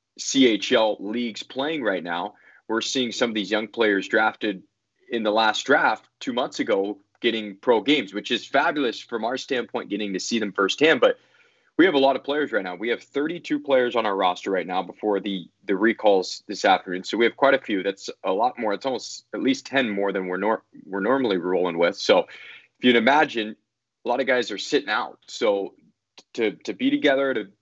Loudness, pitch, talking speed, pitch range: -23 LUFS, 115 Hz, 215 wpm, 100-140 Hz